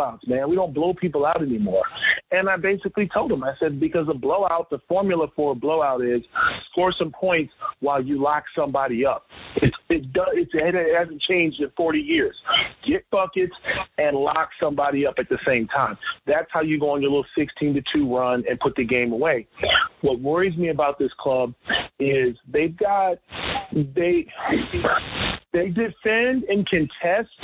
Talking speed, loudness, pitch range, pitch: 175 wpm, -22 LUFS, 140-185 Hz, 160 Hz